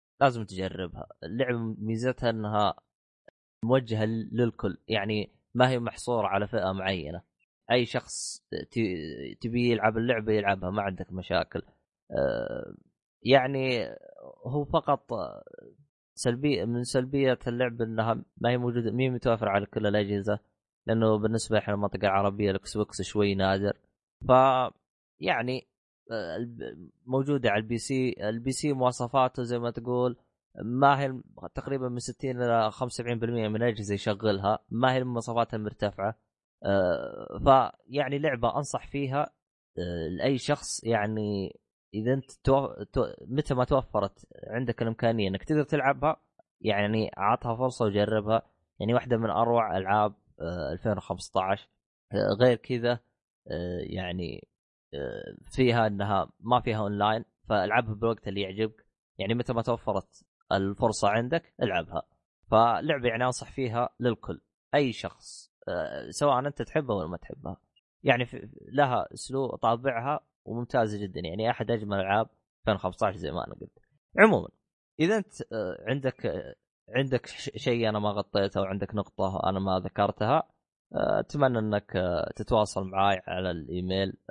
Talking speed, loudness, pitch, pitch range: 120 wpm, -29 LUFS, 115 Hz, 105-125 Hz